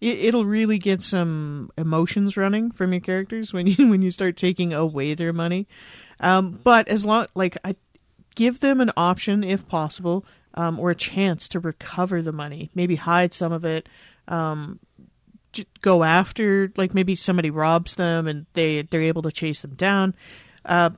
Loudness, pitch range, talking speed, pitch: -22 LUFS, 165-195 Hz, 170 wpm, 180 Hz